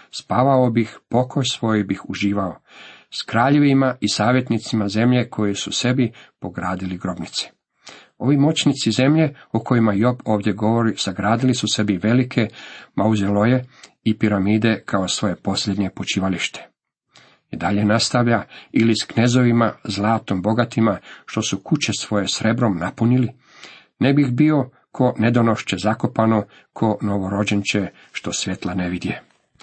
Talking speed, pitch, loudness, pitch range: 125 wpm, 110 Hz, -20 LUFS, 100-125 Hz